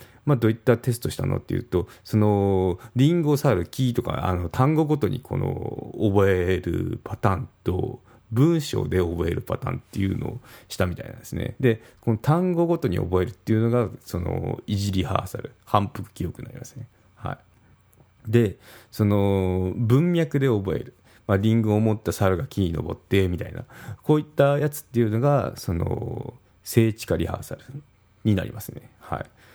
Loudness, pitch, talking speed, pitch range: -24 LUFS, 115 Hz, 330 characters per minute, 100-125 Hz